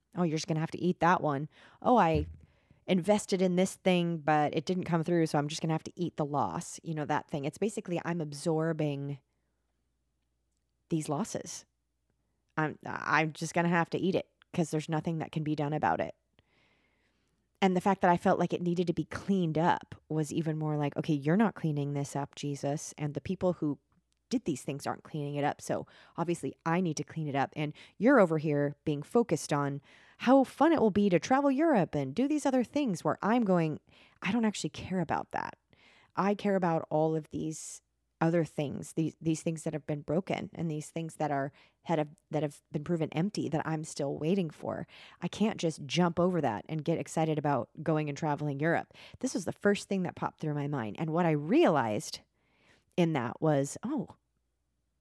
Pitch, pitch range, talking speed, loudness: 160 Hz, 145-175 Hz, 210 wpm, -31 LUFS